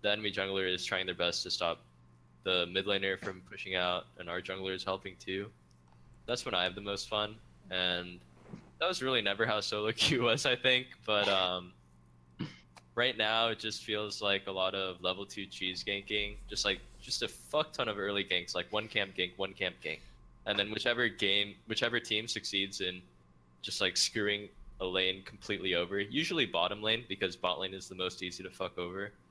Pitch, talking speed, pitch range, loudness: 95 Hz, 200 wpm, 90-105 Hz, -33 LUFS